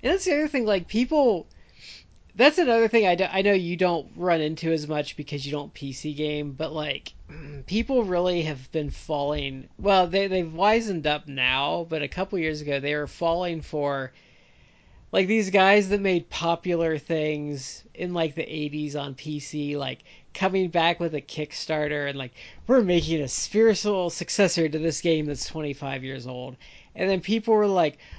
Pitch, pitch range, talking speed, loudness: 160 Hz, 150-190 Hz, 180 wpm, -25 LUFS